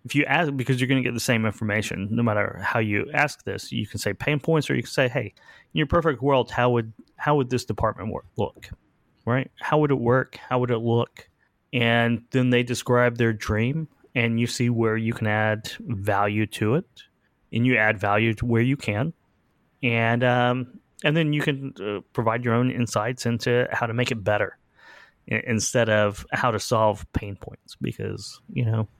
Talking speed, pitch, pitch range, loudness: 205 wpm, 120 Hz, 110-130 Hz, -24 LUFS